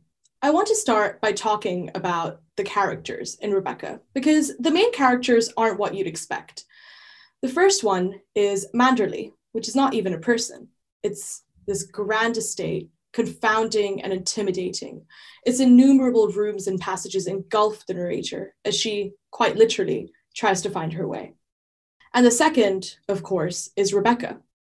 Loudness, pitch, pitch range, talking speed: -22 LUFS, 210 Hz, 195-245 Hz, 150 wpm